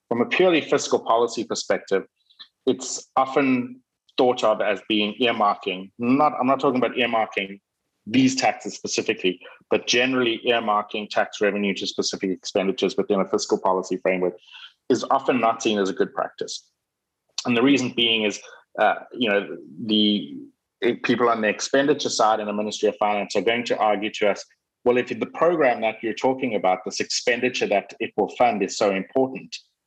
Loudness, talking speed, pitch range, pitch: -22 LUFS, 175 wpm, 105-130 Hz, 115 Hz